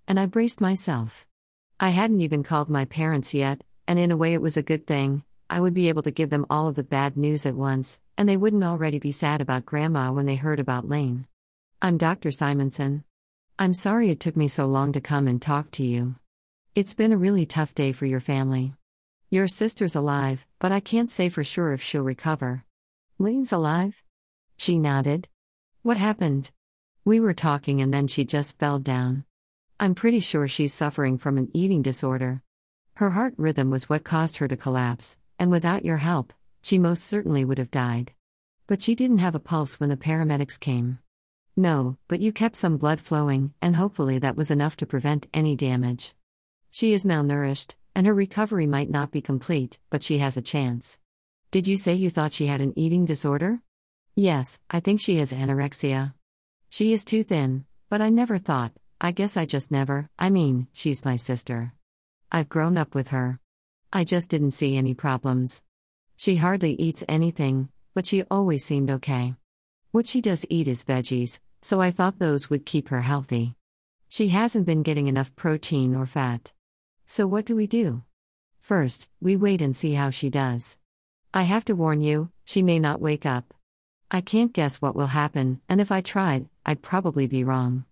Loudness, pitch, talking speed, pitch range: -24 LUFS, 145 Hz, 190 wpm, 130-180 Hz